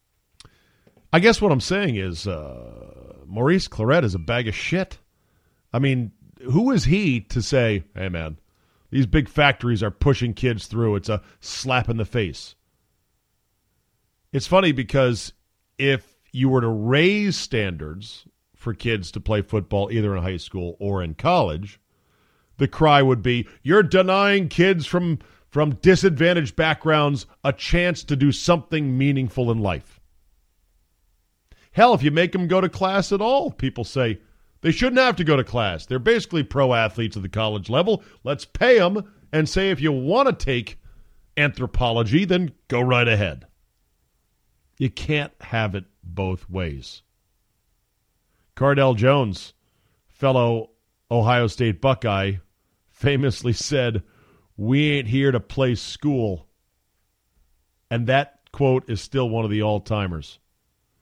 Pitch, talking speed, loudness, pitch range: 120 Hz, 145 wpm, -21 LUFS, 100-145 Hz